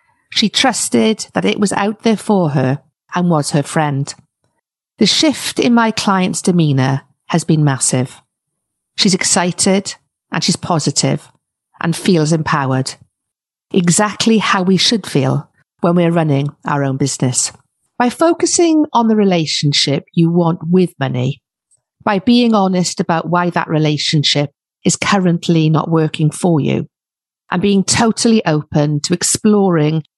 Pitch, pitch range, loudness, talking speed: 170 Hz, 150-200 Hz, -14 LUFS, 135 wpm